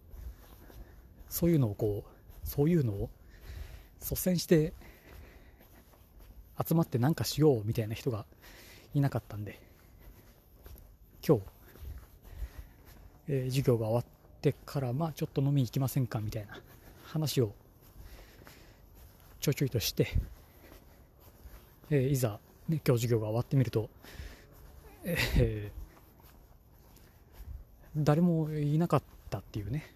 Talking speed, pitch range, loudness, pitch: 230 characters per minute, 90-140 Hz, -32 LUFS, 110 Hz